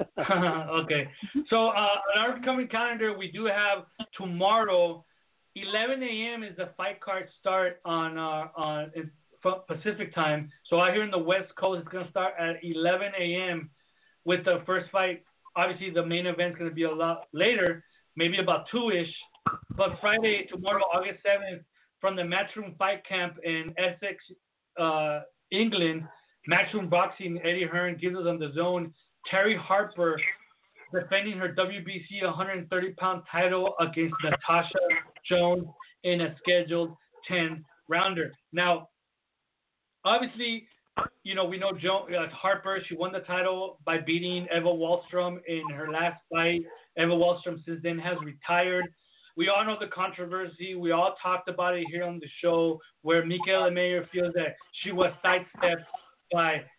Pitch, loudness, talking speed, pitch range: 180 Hz, -28 LUFS, 150 wpm, 170-190 Hz